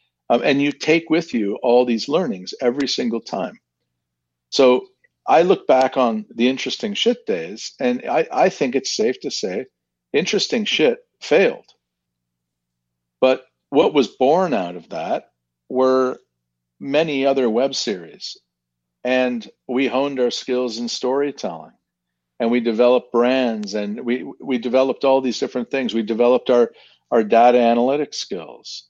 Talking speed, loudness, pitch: 145 wpm, -19 LUFS, 120 Hz